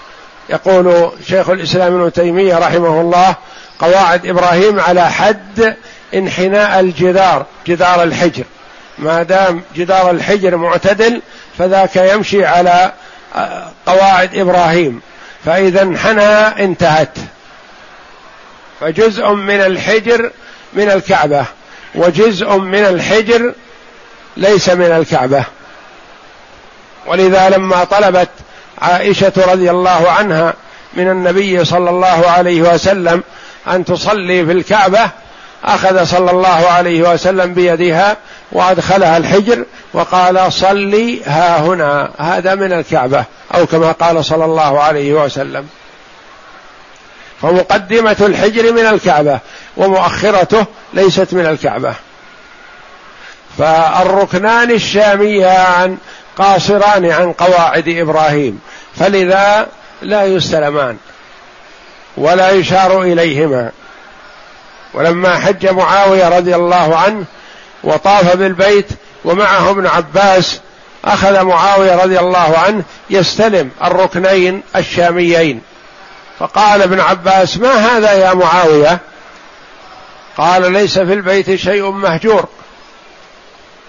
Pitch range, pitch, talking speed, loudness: 175-195 Hz, 185 Hz, 95 wpm, -10 LUFS